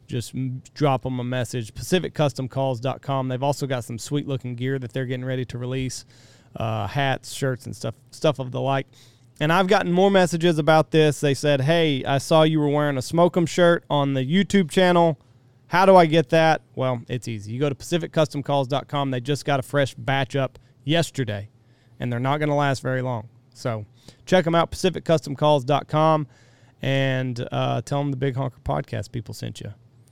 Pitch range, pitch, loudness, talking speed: 125-150 Hz, 135 Hz, -22 LUFS, 185 wpm